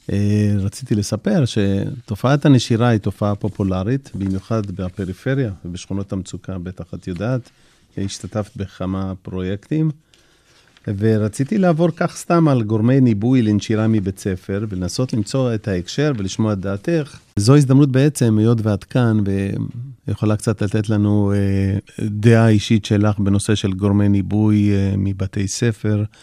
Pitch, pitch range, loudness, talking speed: 105 Hz, 100-120 Hz, -18 LUFS, 120 wpm